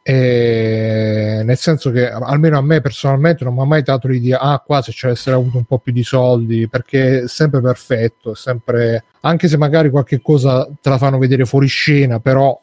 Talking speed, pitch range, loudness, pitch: 200 wpm, 125-140 Hz, -14 LUFS, 130 Hz